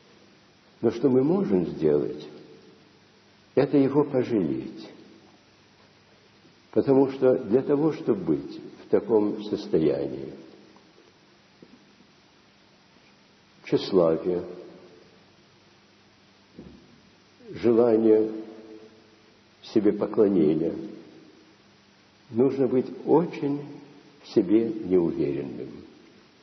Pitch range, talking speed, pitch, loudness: 110-145 Hz, 60 wpm, 125 Hz, -24 LUFS